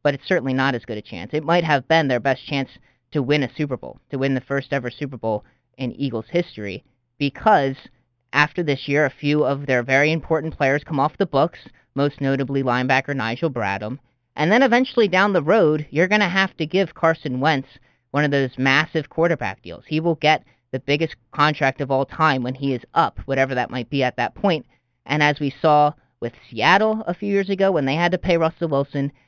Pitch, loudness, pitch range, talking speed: 140 Hz, -20 LUFS, 130-160 Hz, 220 wpm